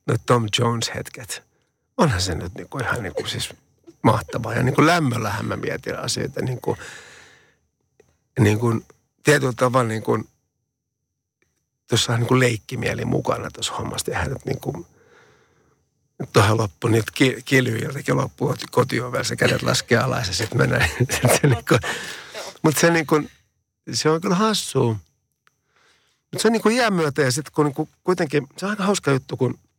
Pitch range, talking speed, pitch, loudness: 115-155 Hz, 145 wpm, 130 Hz, -21 LUFS